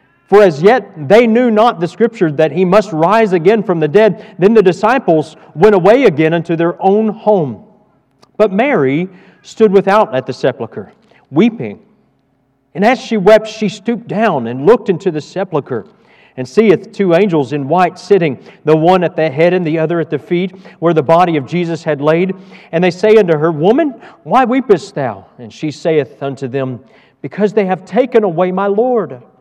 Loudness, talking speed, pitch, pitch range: -12 LUFS, 190 wpm, 185 Hz, 160-215 Hz